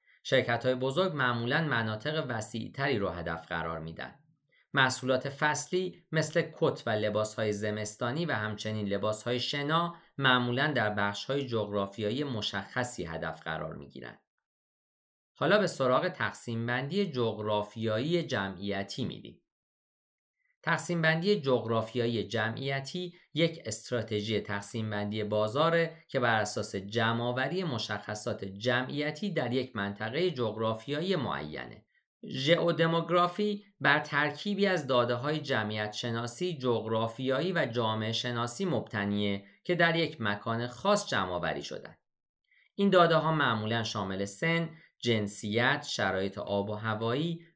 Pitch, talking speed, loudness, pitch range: 120 Hz, 115 wpm, -31 LUFS, 105-155 Hz